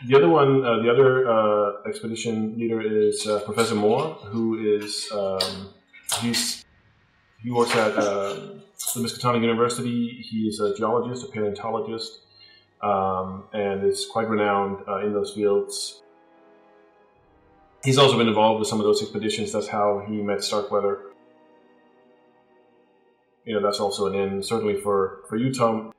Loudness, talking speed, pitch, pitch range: -23 LUFS, 145 wpm, 105 Hz, 100-115 Hz